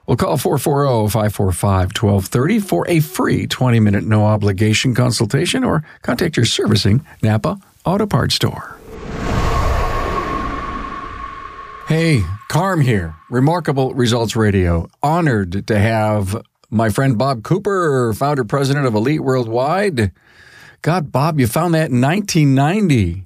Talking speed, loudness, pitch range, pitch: 110 wpm, -16 LUFS, 110-155 Hz, 130 Hz